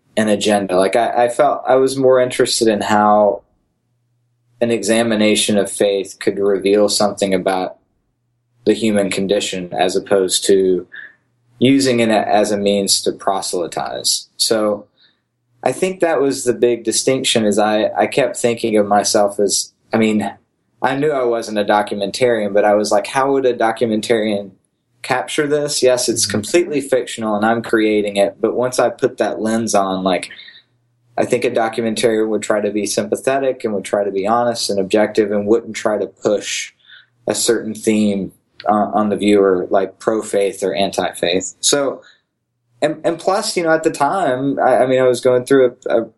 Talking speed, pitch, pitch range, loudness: 175 wpm, 110 Hz, 105-120 Hz, -16 LUFS